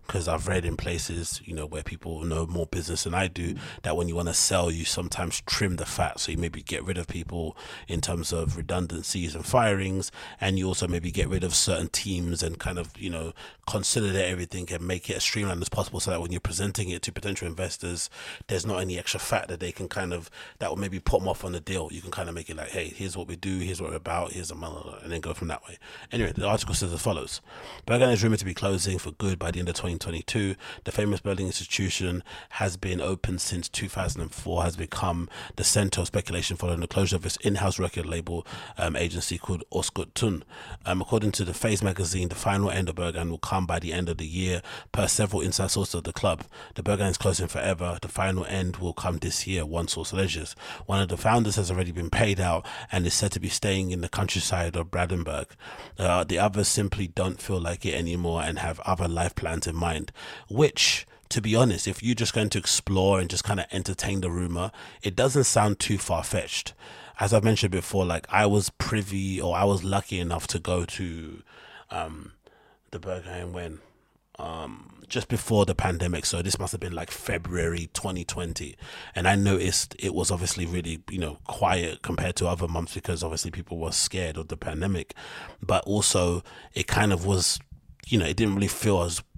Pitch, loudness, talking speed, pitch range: 90 Hz, -27 LUFS, 220 wpm, 85-100 Hz